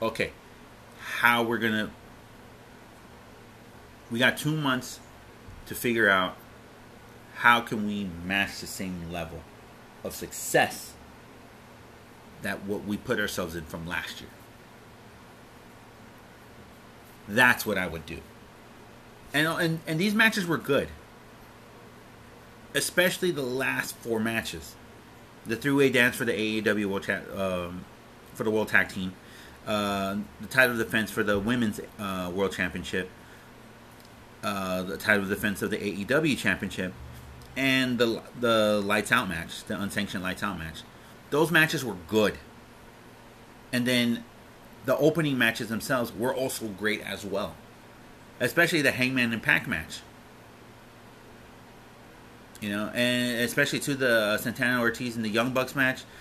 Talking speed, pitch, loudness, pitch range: 135 wpm, 115 Hz, -27 LUFS, 95-125 Hz